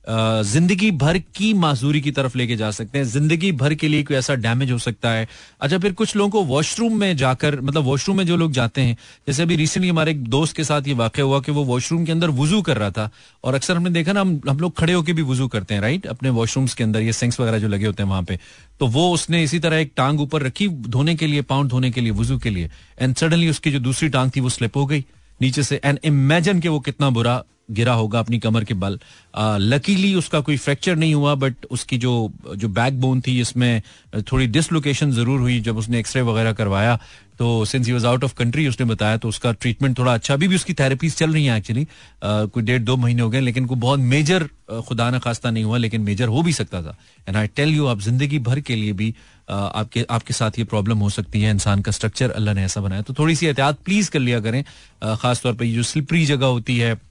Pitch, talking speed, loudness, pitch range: 130 Hz, 240 wpm, -20 LUFS, 115-150 Hz